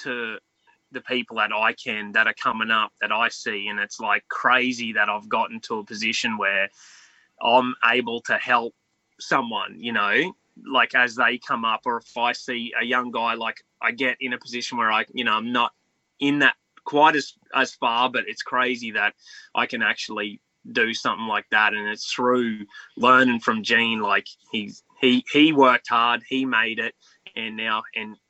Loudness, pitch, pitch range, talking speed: -22 LUFS, 120 Hz, 115-125 Hz, 190 wpm